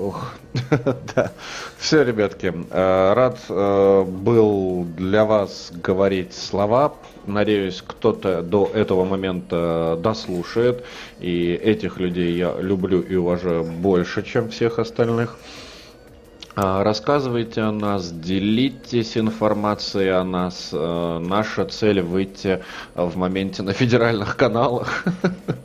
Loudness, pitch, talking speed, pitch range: -21 LUFS, 100 Hz, 110 wpm, 90-115 Hz